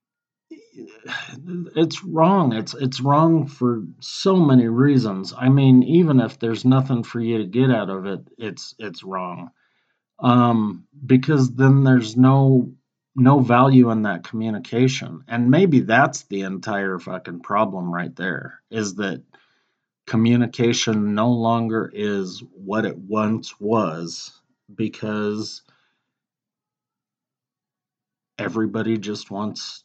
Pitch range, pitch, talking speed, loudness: 105-130 Hz, 115 Hz, 115 wpm, -19 LUFS